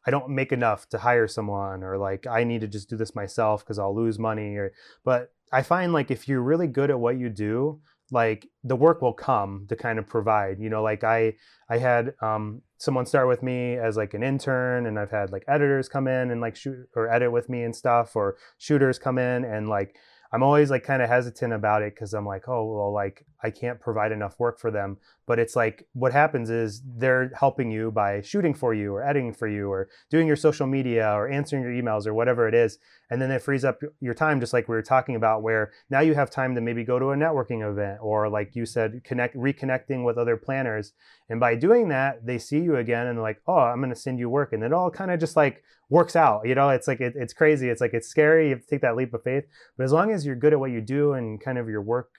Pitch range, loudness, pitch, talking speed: 110-135 Hz, -25 LUFS, 120 Hz, 260 wpm